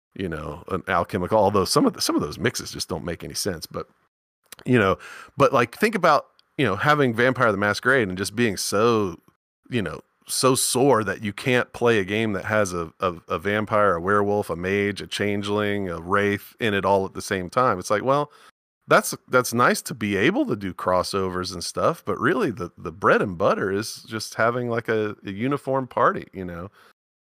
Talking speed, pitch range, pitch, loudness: 210 wpm, 95-115 Hz, 100 Hz, -23 LUFS